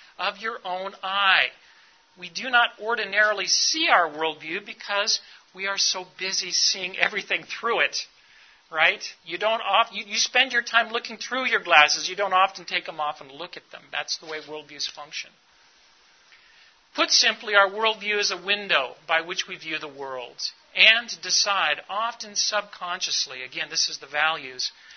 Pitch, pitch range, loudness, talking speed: 195 Hz, 170-220 Hz, -23 LUFS, 170 wpm